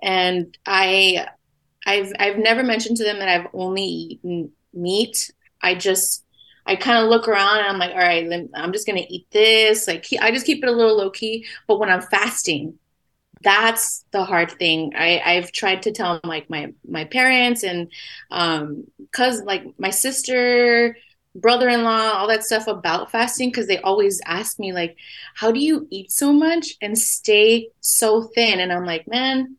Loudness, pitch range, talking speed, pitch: -18 LUFS, 180-230 Hz, 180 wpm, 205 Hz